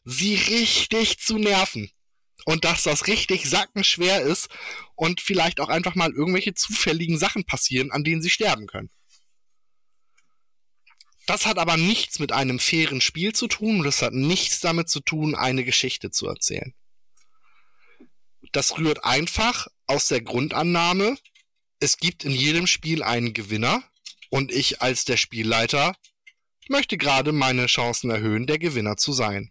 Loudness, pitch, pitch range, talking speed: -21 LUFS, 165 Hz, 135-205 Hz, 145 wpm